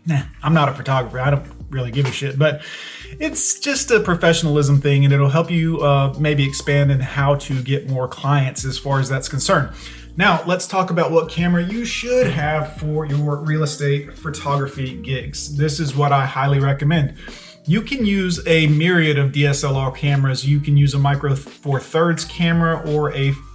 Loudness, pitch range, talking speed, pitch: -18 LUFS, 140-165 Hz, 190 wpm, 145 Hz